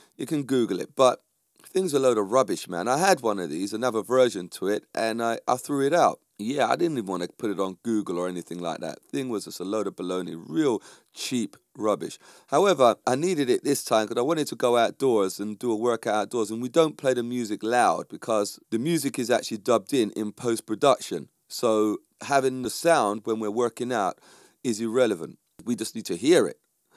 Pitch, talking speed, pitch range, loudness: 120 Hz, 225 wpm, 105-130 Hz, -25 LUFS